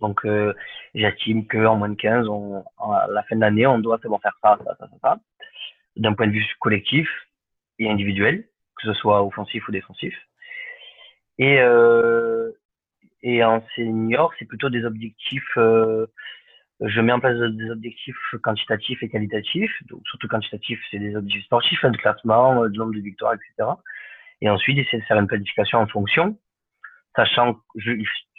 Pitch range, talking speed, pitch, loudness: 105-120 Hz, 175 wpm, 115 Hz, -21 LUFS